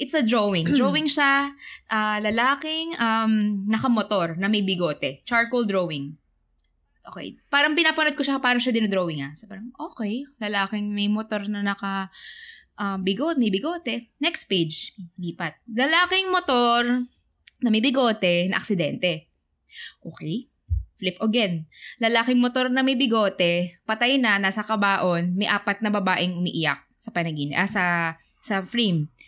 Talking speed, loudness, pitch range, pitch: 140 wpm, -22 LUFS, 185-250 Hz, 215 Hz